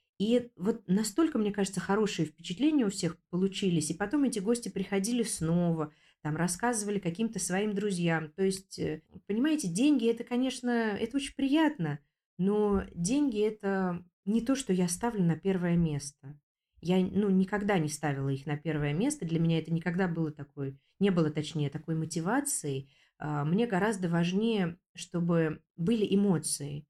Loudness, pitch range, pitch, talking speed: -30 LUFS, 160-215 Hz, 185 Hz, 150 wpm